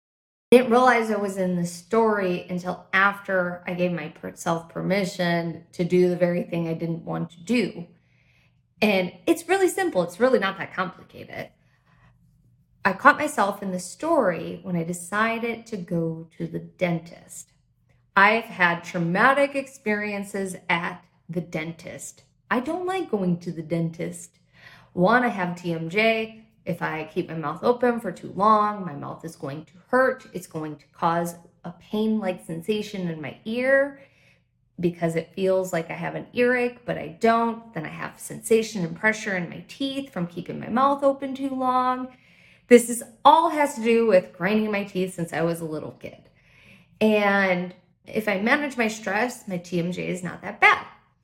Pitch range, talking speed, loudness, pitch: 170-230 Hz, 170 wpm, -24 LUFS, 185 Hz